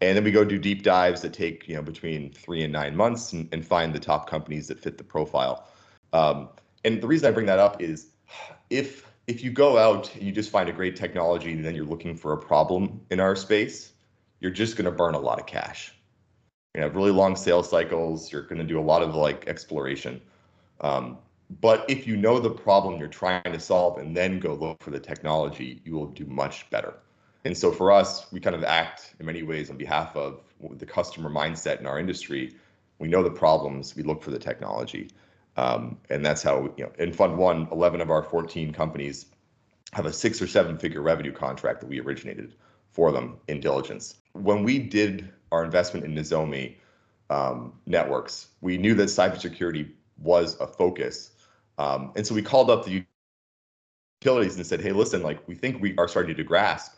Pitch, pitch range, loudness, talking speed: 85 Hz, 75-100 Hz, -25 LUFS, 210 wpm